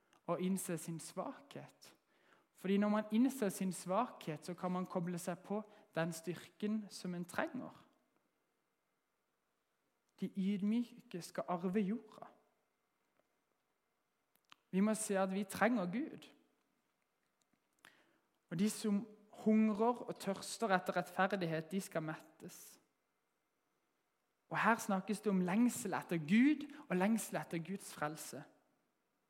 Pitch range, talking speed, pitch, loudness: 180-215 Hz, 115 wpm, 195 Hz, -39 LUFS